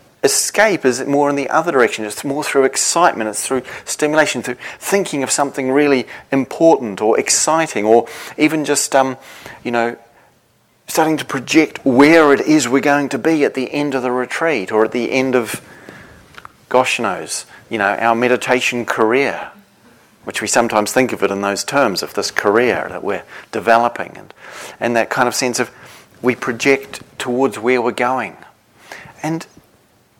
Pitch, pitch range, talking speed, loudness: 130 Hz, 120-145 Hz, 170 wpm, -16 LUFS